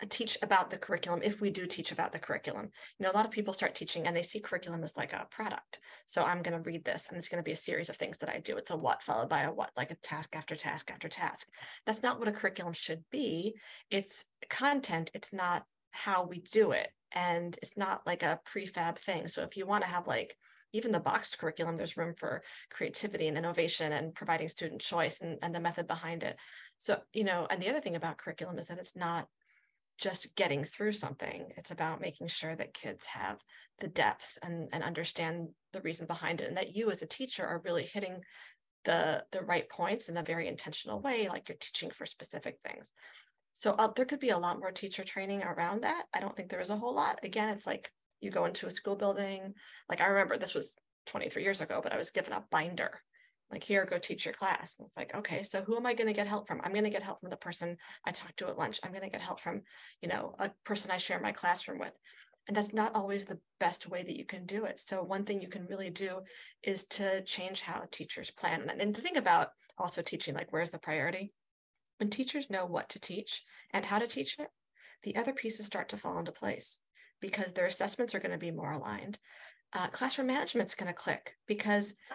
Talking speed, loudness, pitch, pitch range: 235 wpm, -36 LUFS, 190 Hz, 170-210 Hz